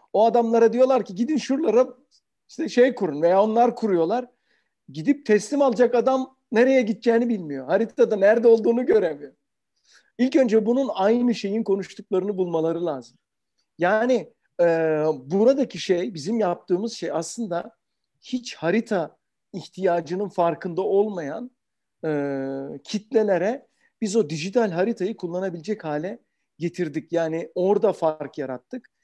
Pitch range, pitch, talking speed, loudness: 170-240 Hz, 210 Hz, 120 wpm, -23 LUFS